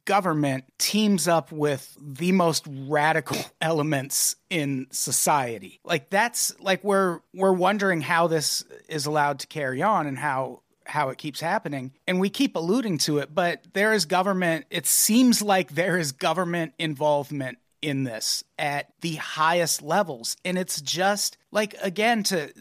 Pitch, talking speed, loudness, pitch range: 165 Hz, 155 wpm, -24 LUFS, 145-195 Hz